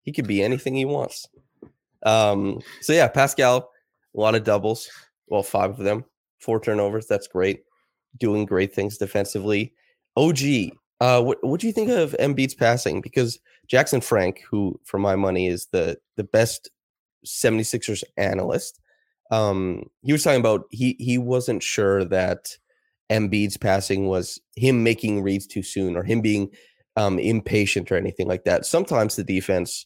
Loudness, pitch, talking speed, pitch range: -22 LUFS, 110 Hz, 155 wpm, 100-125 Hz